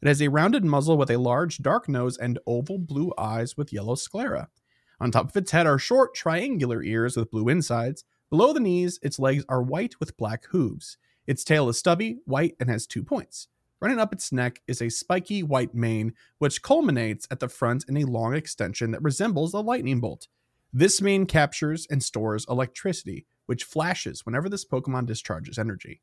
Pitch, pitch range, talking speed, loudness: 135 Hz, 120-170 Hz, 195 wpm, -25 LUFS